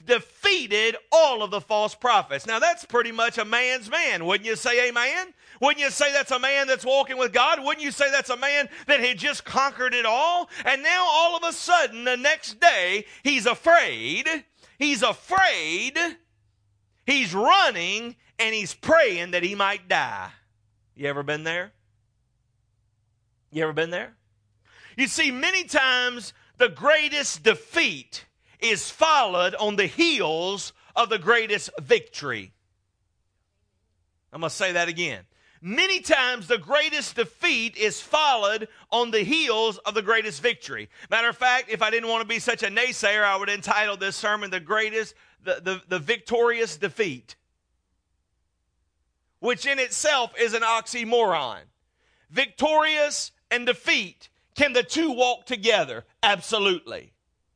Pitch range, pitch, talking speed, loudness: 180-280 Hz, 230 Hz, 150 wpm, -22 LUFS